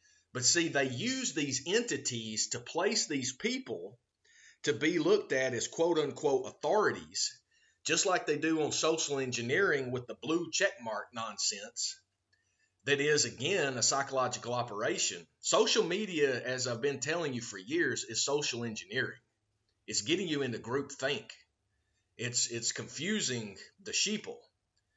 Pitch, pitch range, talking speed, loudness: 140 Hz, 120-190 Hz, 145 wpm, -32 LUFS